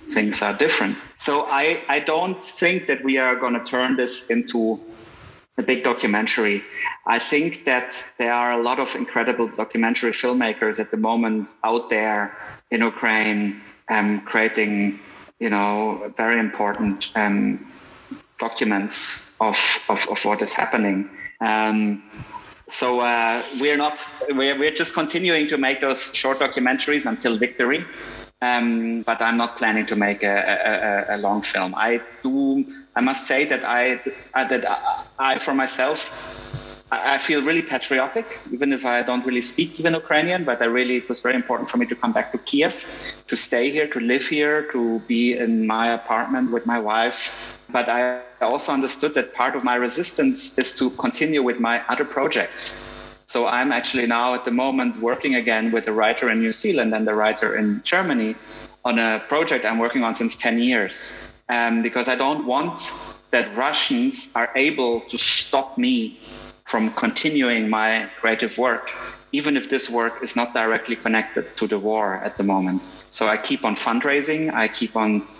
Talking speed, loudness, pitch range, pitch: 175 wpm, -21 LUFS, 110-135 Hz, 120 Hz